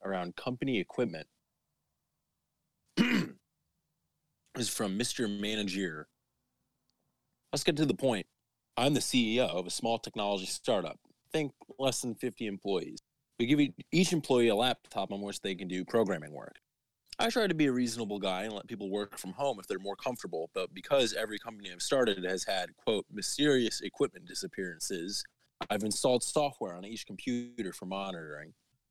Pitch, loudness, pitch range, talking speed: 110 Hz, -33 LUFS, 95-125 Hz, 160 wpm